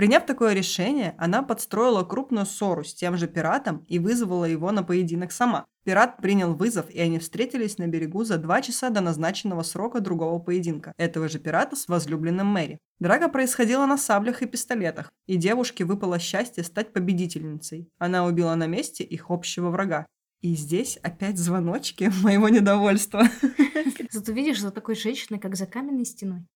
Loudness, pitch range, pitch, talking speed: -25 LUFS, 175-230 Hz, 195 Hz, 165 wpm